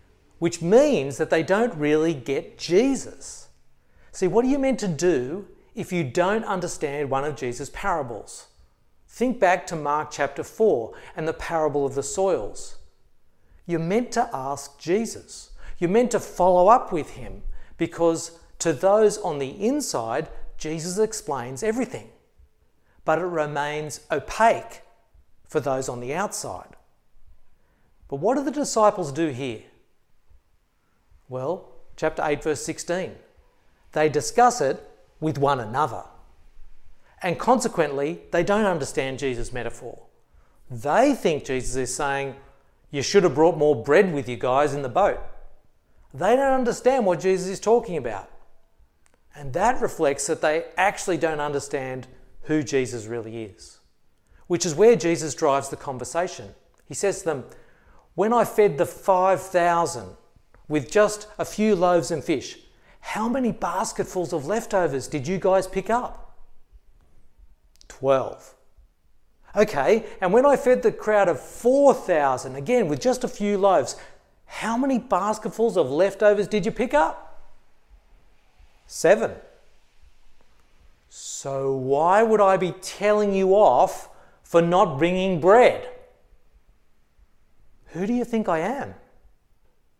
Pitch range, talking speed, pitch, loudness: 140-210 Hz, 135 wpm, 170 Hz, -23 LUFS